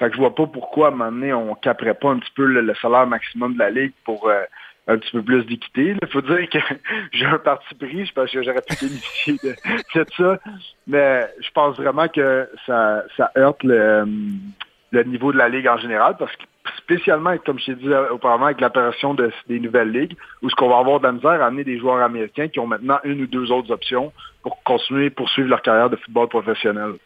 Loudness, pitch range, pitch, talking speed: -19 LUFS, 120-145 Hz, 130 Hz, 245 wpm